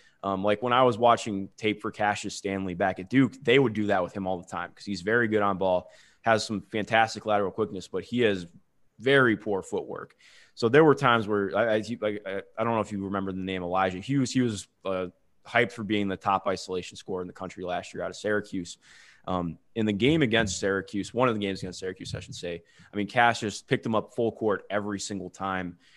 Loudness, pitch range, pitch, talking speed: -27 LUFS, 95-110 Hz, 100 Hz, 235 wpm